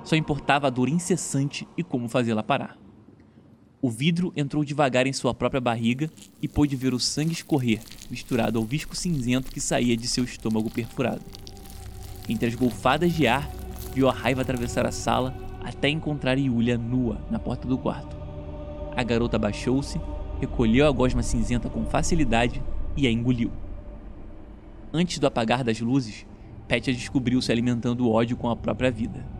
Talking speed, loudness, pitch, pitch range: 160 wpm, -25 LUFS, 125 Hz, 115-140 Hz